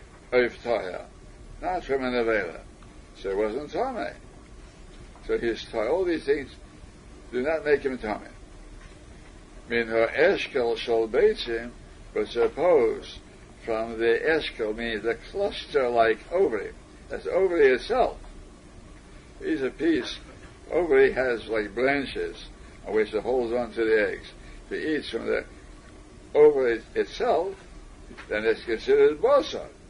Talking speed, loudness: 130 wpm, -25 LUFS